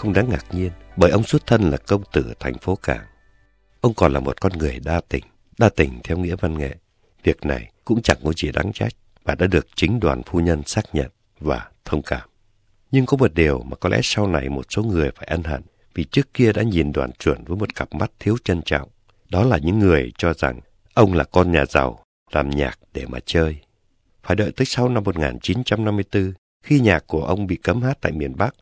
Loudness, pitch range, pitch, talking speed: -21 LUFS, 80-105 Hz, 90 Hz, 230 wpm